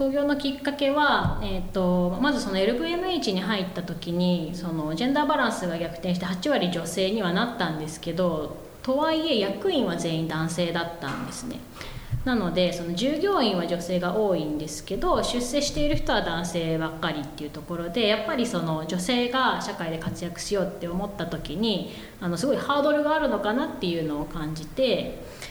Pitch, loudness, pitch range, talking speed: 180 Hz, -26 LUFS, 165-240 Hz, 380 characters per minute